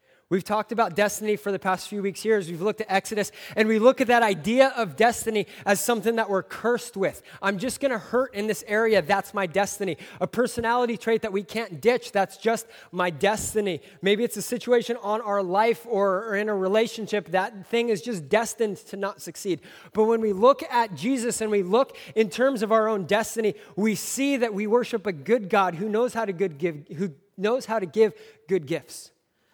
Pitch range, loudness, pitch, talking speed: 195-230 Hz, -25 LUFS, 215 Hz, 215 wpm